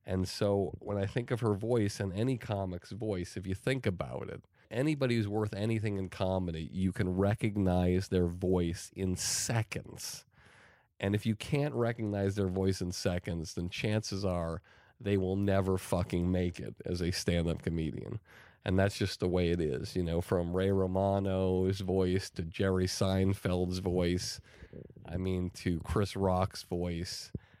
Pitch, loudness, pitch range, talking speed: 95 Hz, -33 LUFS, 90-105 Hz, 165 wpm